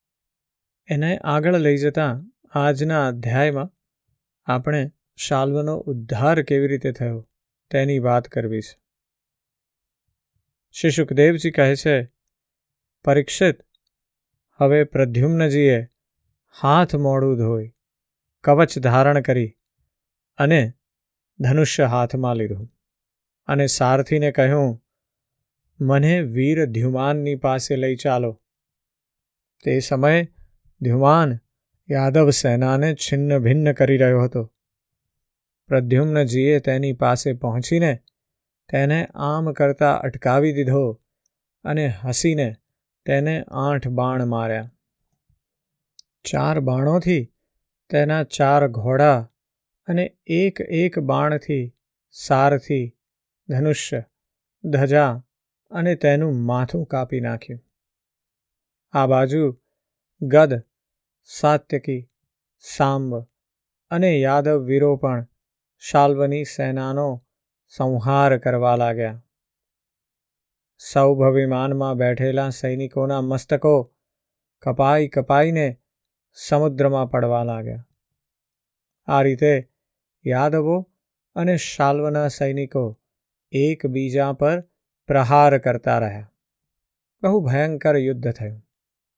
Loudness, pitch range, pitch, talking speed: -20 LUFS, 125-150 Hz, 140 Hz, 80 wpm